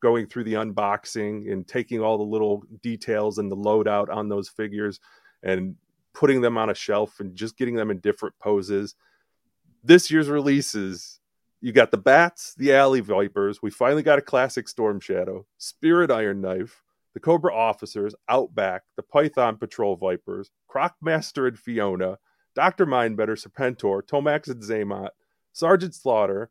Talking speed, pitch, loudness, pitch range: 155 wpm, 110 Hz, -23 LUFS, 105-135 Hz